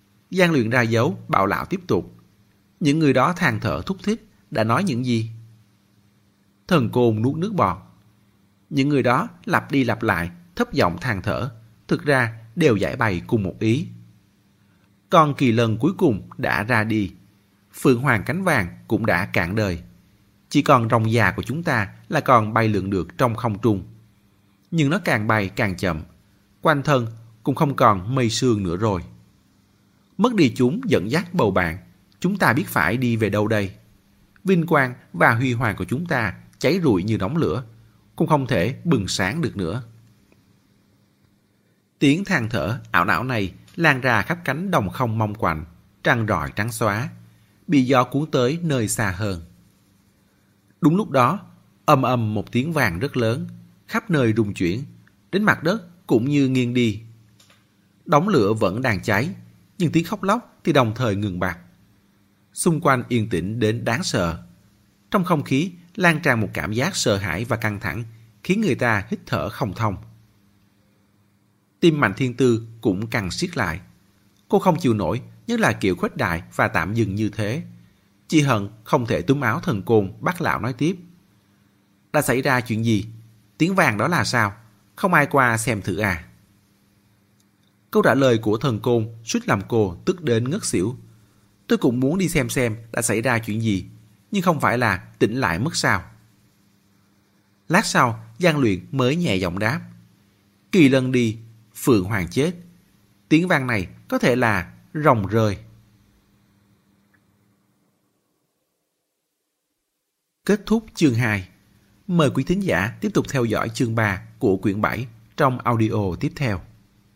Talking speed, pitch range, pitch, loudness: 170 wpm, 100-135 Hz, 110 Hz, -21 LUFS